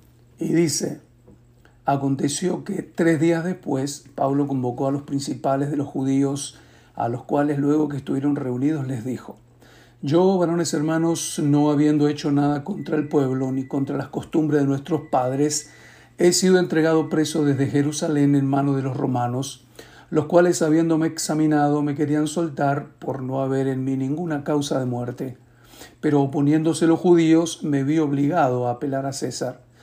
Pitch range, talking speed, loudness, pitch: 135-155 Hz, 160 wpm, -22 LUFS, 145 Hz